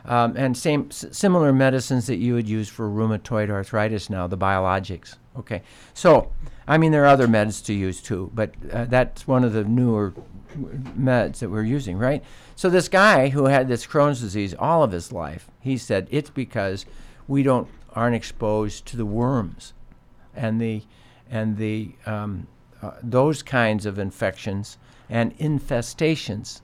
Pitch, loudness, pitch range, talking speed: 120 Hz, -22 LUFS, 105-130 Hz, 165 wpm